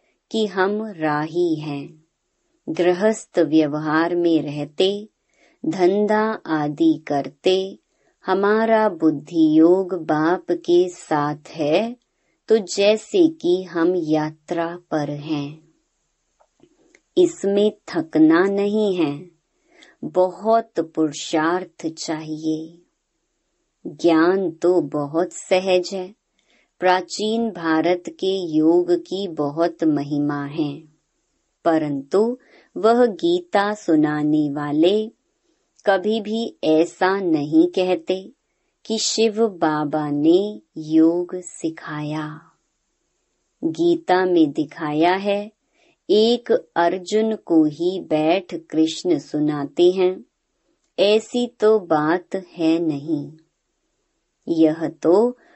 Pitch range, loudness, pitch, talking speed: 155-205 Hz, -20 LUFS, 175 Hz, 85 wpm